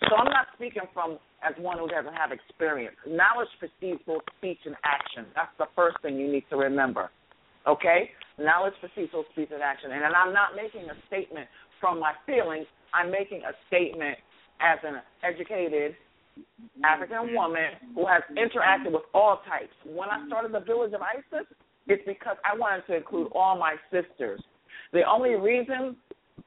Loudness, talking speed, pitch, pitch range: -27 LUFS, 170 wpm, 180 Hz, 160-220 Hz